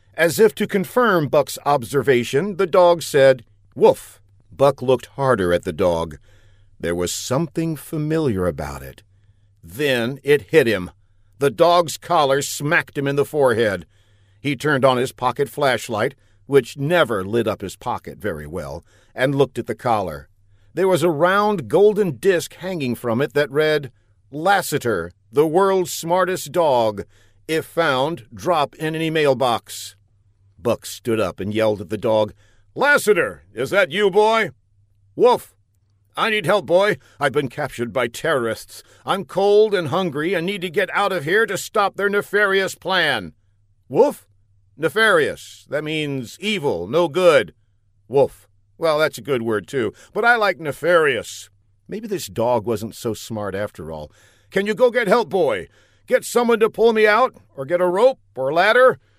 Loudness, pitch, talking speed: -19 LUFS, 135 Hz, 160 wpm